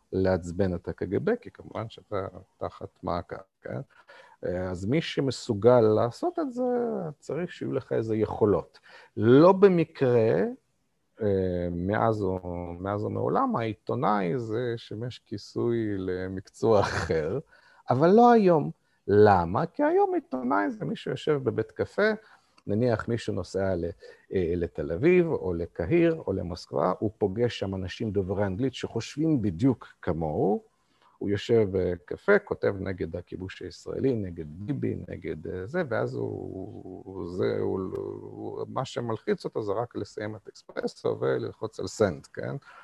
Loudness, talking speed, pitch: -27 LUFS, 125 wpm, 115 Hz